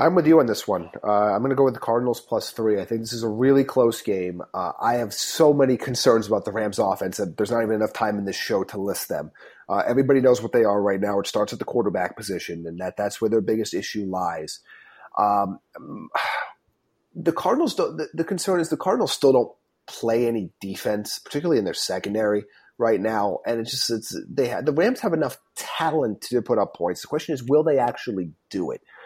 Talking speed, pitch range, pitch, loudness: 230 wpm, 105-135 Hz, 115 Hz, -23 LUFS